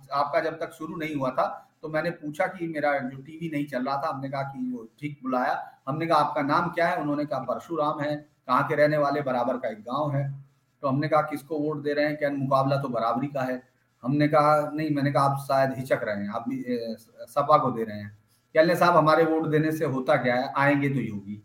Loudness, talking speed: -26 LUFS, 245 wpm